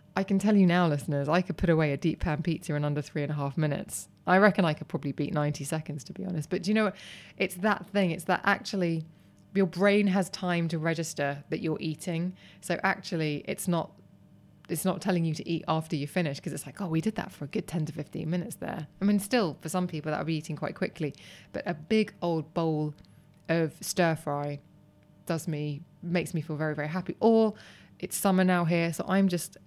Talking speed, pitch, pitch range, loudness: 235 wpm, 170 Hz, 155-185 Hz, -29 LUFS